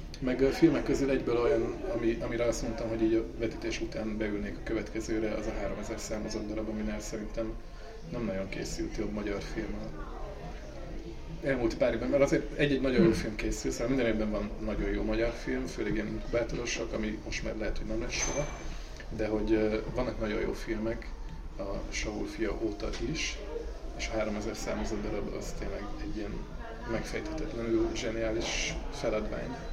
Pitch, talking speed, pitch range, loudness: 110 Hz, 170 wpm, 105-115 Hz, -33 LUFS